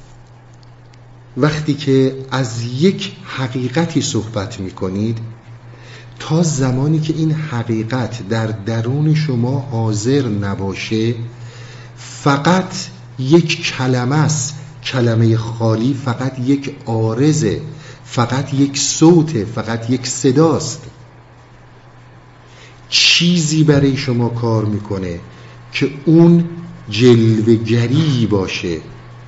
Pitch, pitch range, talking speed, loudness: 125 Hz, 115-140 Hz, 85 wpm, -16 LUFS